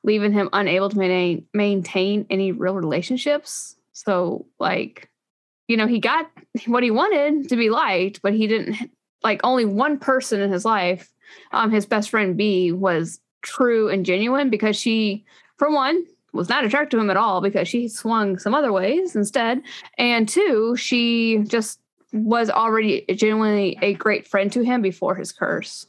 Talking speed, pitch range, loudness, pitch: 170 wpm, 195-245 Hz, -20 LUFS, 220 Hz